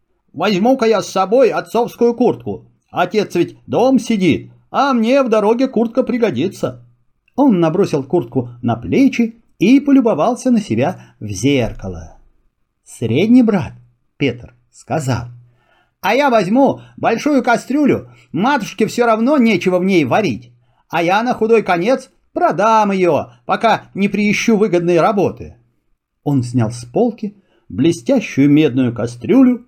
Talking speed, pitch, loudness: 125 wpm, 195 Hz, -15 LUFS